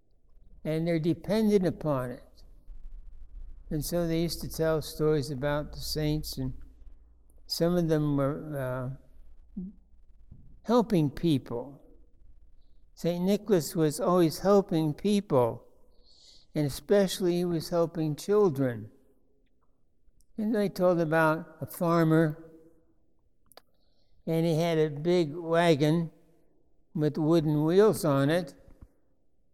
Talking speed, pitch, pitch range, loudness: 105 wpm, 160 Hz, 135-170 Hz, -28 LUFS